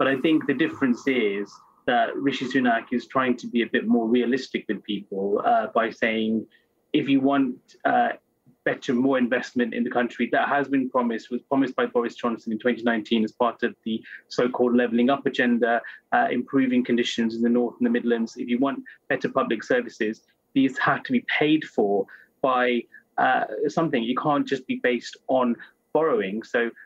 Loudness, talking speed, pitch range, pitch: -24 LUFS, 185 wpm, 115-135 Hz, 125 Hz